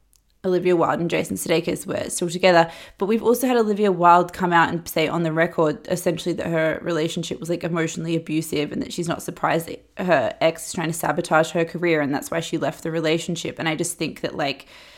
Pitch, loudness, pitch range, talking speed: 170 Hz, -22 LUFS, 160-180 Hz, 225 wpm